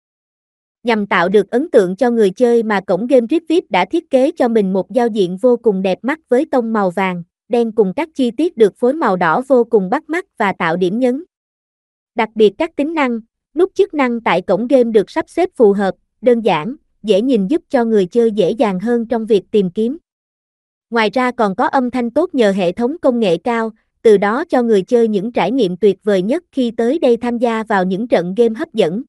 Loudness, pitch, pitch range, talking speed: -15 LUFS, 235 Hz, 210-265 Hz, 230 wpm